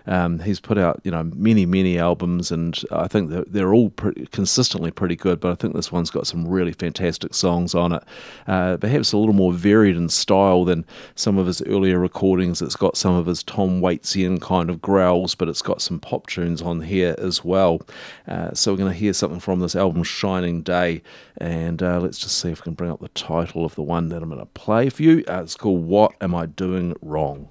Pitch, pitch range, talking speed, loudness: 90 Hz, 85-95 Hz, 235 wpm, -20 LUFS